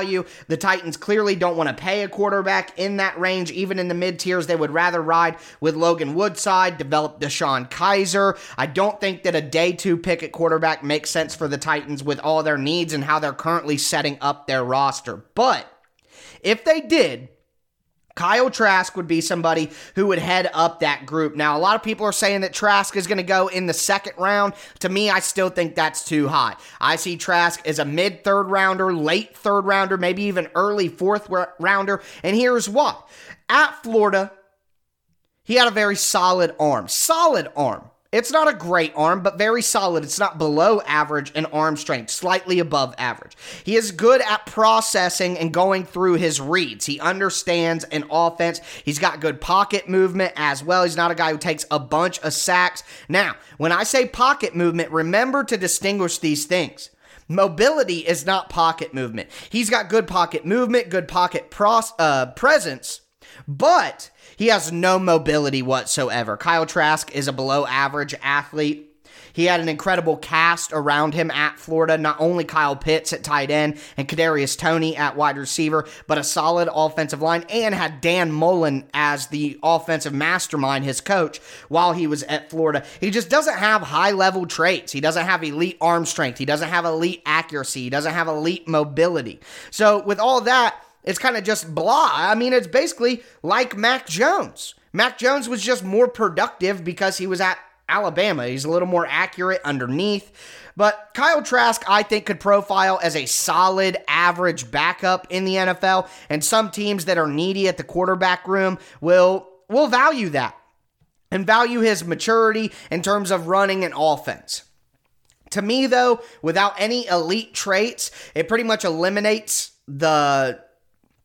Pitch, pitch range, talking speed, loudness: 175 Hz, 155-195 Hz, 175 wpm, -20 LUFS